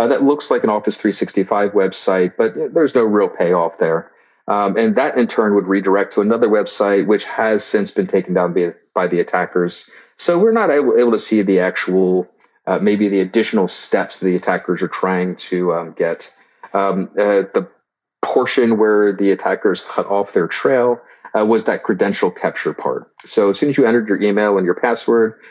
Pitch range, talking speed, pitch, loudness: 95-115 Hz, 195 wpm, 100 Hz, -17 LUFS